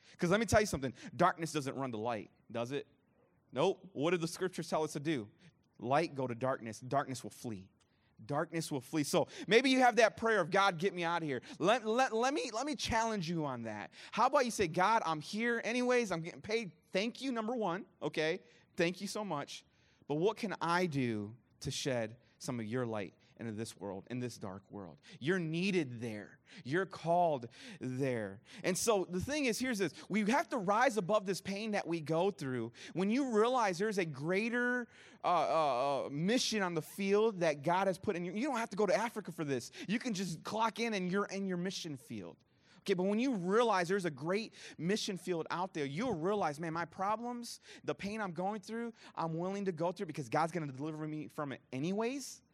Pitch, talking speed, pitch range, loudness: 175 Hz, 215 wpm, 140-210 Hz, -35 LUFS